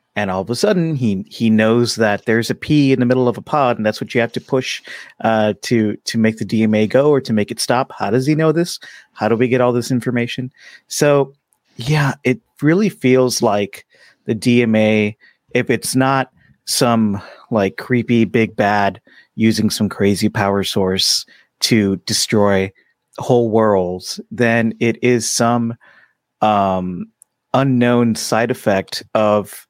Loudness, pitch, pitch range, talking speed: -16 LUFS, 115 Hz, 105-130 Hz, 170 wpm